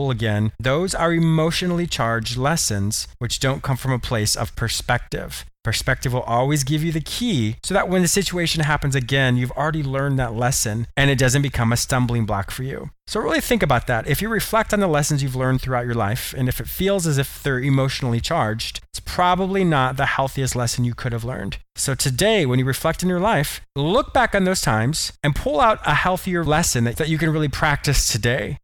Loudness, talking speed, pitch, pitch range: -20 LUFS, 215 wpm, 135 Hz, 120-160 Hz